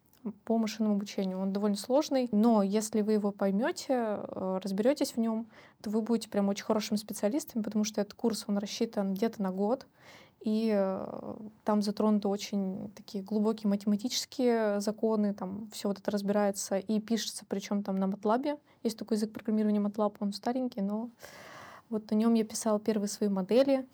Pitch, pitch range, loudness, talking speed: 215 Hz, 205-225 Hz, -31 LUFS, 165 wpm